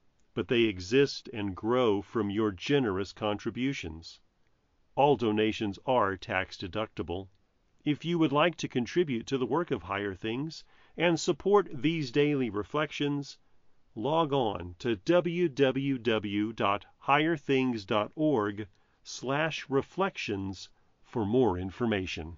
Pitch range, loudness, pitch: 105-145 Hz, -30 LUFS, 120 Hz